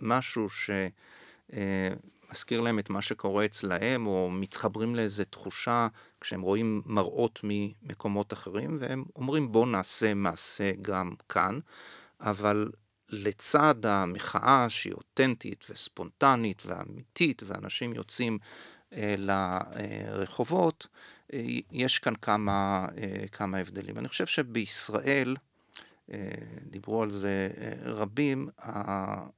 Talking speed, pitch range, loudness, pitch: 110 wpm, 100-115 Hz, -30 LUFS, 105 Hz